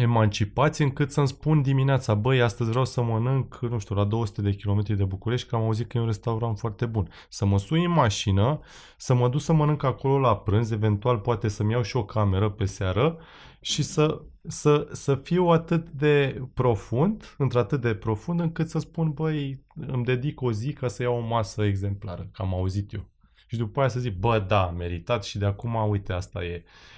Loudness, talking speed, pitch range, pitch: -25 LUFS, 205 wpm, 105-140 Hz, 120 Hz